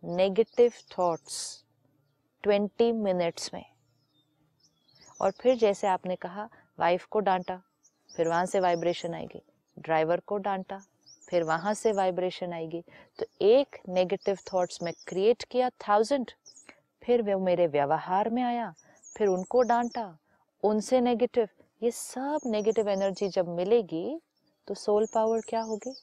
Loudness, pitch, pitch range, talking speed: -28 LUFS, 195 Hz, 175-230 Hz, 130 wpm